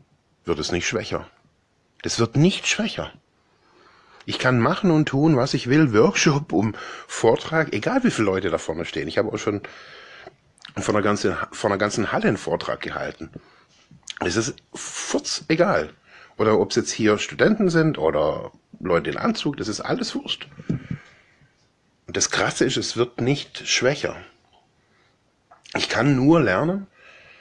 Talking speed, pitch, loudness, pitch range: 155 wpm, 150 Hz, -22 LUFS, 120-180 Hz